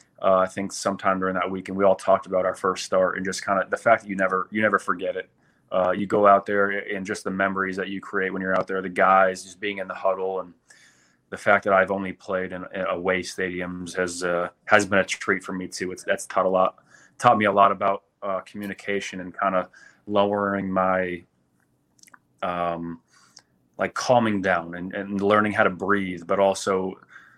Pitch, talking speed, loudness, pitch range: 95 Hz, 220 wpm, -23 LUFS, 95-100 Hz